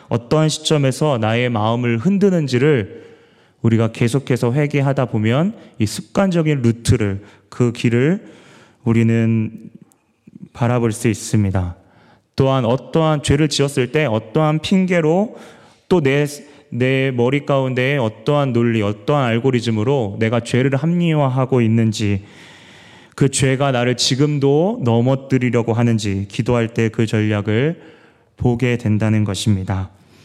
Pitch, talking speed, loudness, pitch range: 125 Hz, 275 characters per minute, -17 LUFS, 115-145 Hz